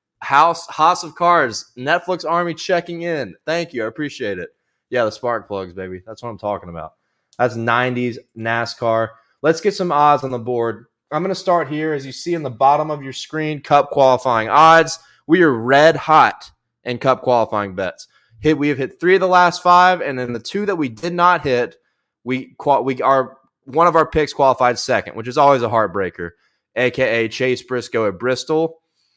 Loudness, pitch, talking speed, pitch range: -17 LUFS, 135 Hz, 195 wpm, 120-165 Hz